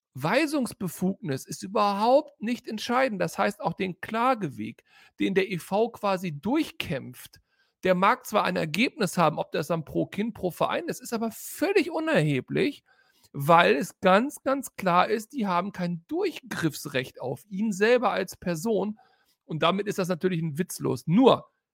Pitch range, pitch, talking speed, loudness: 175-235 Hz, 195 Hz, 155 wpm, -26 LUFS